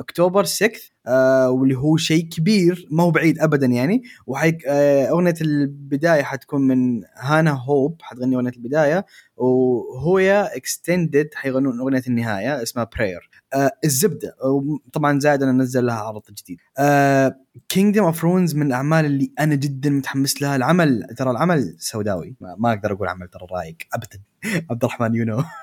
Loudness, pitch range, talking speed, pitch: -19 LUFS, 125-160 Hz, 150 wpm, 140 Hz